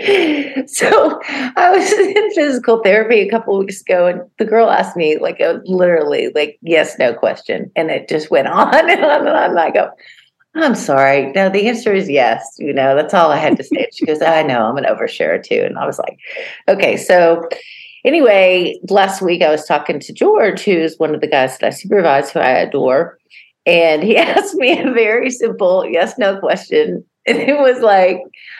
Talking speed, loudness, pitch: 210 wpm, -13 LUFS, 220 Hz